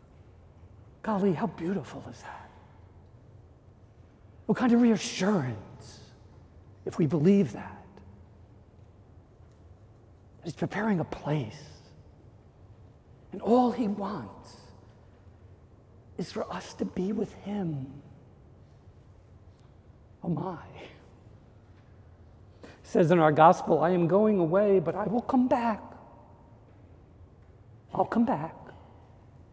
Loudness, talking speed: -27 LUFS, 95 wpm